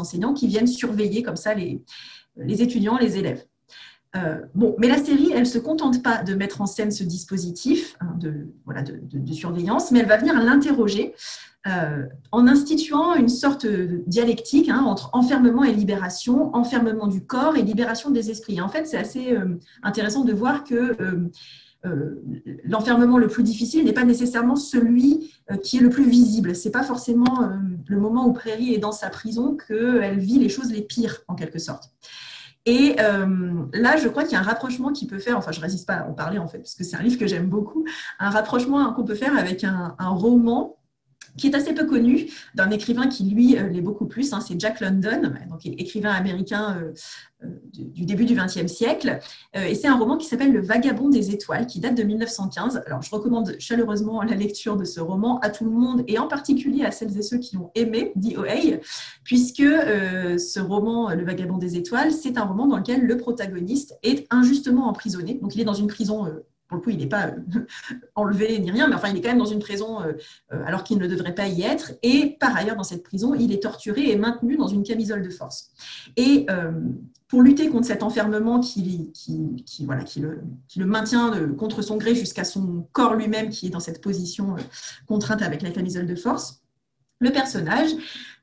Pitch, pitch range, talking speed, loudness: 220 Hz, 190-245 Hz, 210 wpm, -22 LUFS